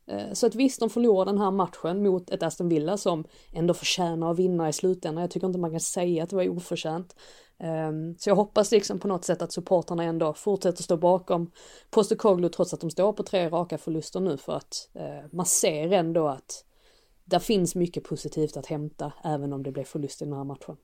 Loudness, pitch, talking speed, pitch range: -27 LUFS, 175 Hz, 215 wpm, 160-190 Hz